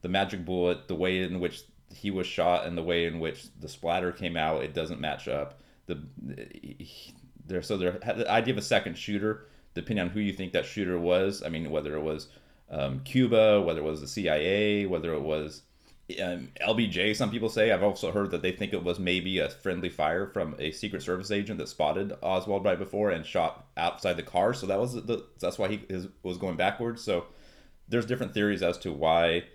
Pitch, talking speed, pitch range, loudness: 90 Hz, 210 wpm, 80-100 Hz, -29 LUFS